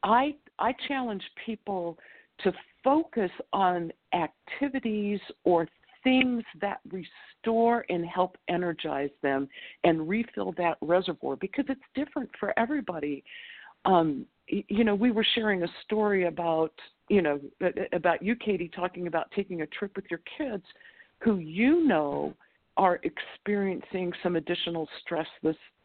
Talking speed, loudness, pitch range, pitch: 130 wpm, -29 LUFS, 170-235 Hz, 195 Hz